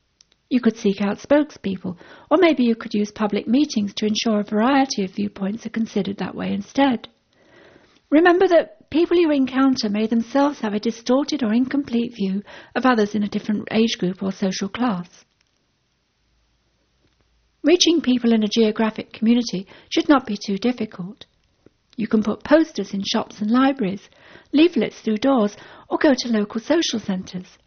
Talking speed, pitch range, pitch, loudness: 160 wpm, 205-270 Hz, 225 Hz, -20 LUFS